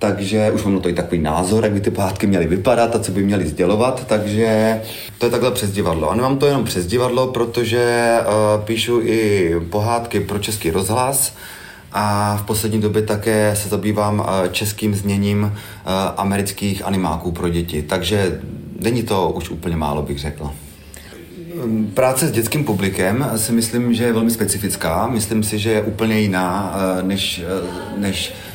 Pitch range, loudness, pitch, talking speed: 95-115 Hz, -18 LUFS, 105 Hz, 170 wpm